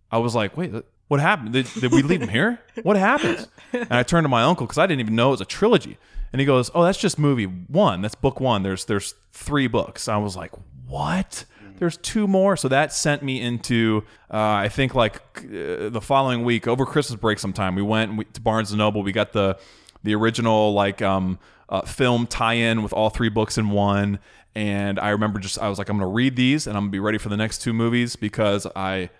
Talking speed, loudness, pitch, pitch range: 230 wpm, -22 LUFS, 110 Hz, 100-130 Hz